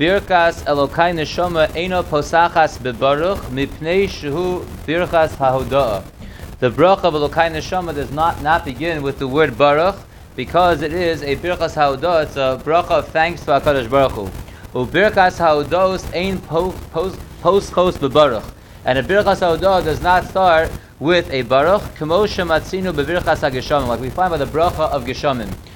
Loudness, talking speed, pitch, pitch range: -17 LUFS, 155 wpm, 155 Hz, 135-175 Hz